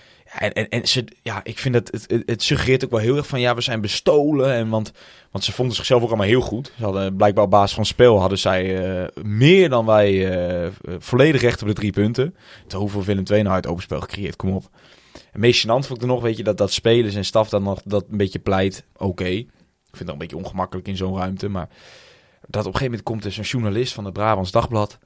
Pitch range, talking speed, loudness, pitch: 95-120 Hz, 255 wpm, -20 LUFS, 105 Hz